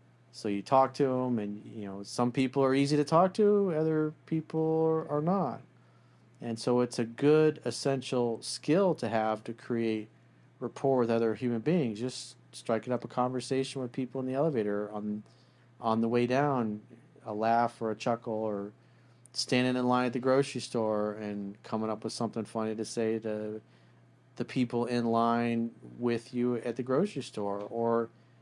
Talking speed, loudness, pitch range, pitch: 175 wpm, -31 LUFS, 110-130 Hz, 120 Hz